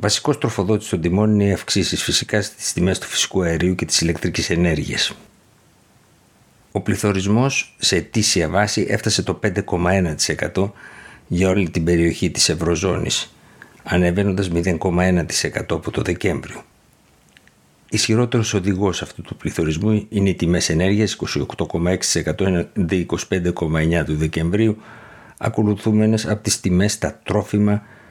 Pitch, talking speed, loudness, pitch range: 95 Hz, 120 wpm, -19 LUFS, 85-105 Hz